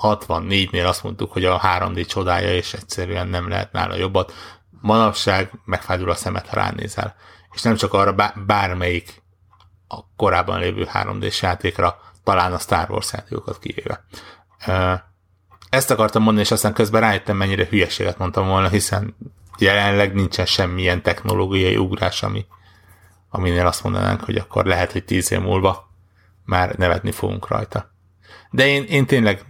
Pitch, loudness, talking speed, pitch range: 95 Hz, -19 LUFS, 145 wpm, 90-110 Hz